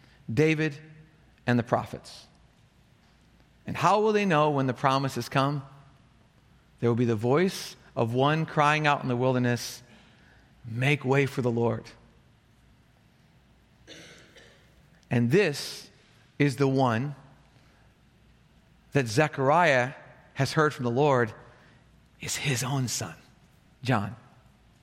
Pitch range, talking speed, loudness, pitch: 120-150 Hz, 115 wpm, -26 LUFS, 135 Hz